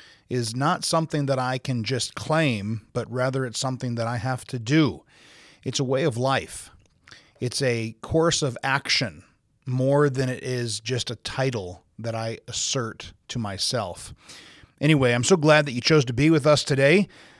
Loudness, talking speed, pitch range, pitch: -24 LUFS, 175 wpm, 120-145 Hz, 130 Hz